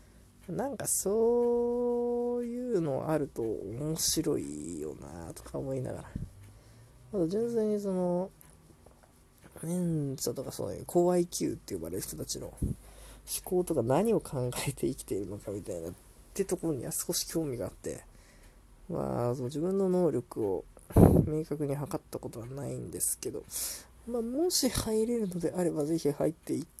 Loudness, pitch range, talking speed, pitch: -32 LUFS, 135-220 Hz, 300 characters per minute, 170 Hz